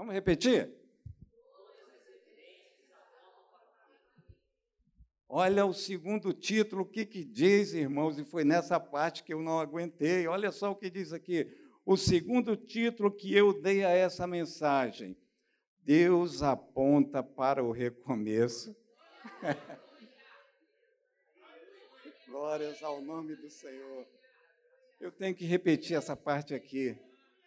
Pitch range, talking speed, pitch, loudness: 150-215 Hz, 110 wpm, 175 Hz, -31 LUFS